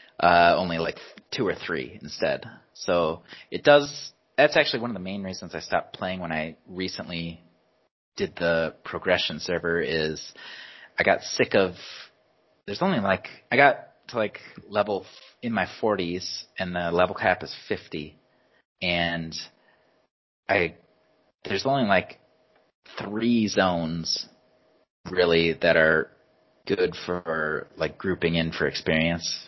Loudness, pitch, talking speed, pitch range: -25 LUFS, 85 Hz, 135 wpm, 80-95 Hz